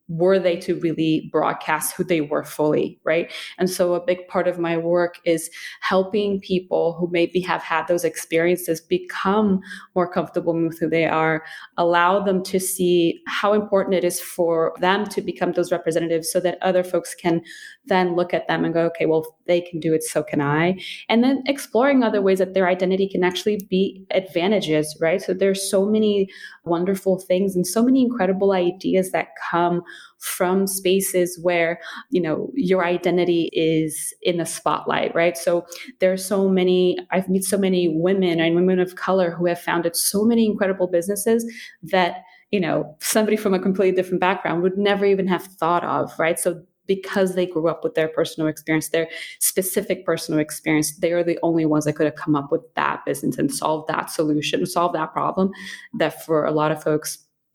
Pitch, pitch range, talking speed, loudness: 180 Hz, 165-190 Hz, 190 wpm, -21 LUFS